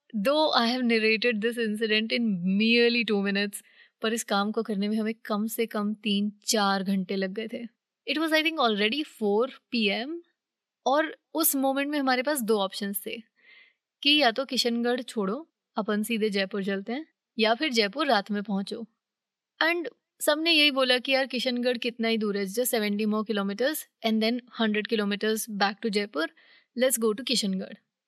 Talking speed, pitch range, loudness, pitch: 180 wpm, 210-255 Hz, -26 LUFS, 225 Hz